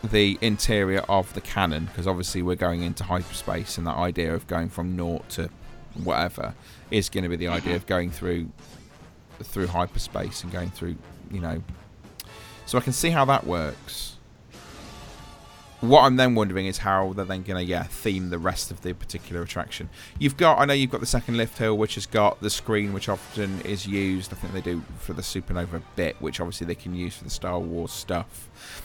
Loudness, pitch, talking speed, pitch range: -26 LUFS, 95 Hz, 205 wpm, 85-105 Hz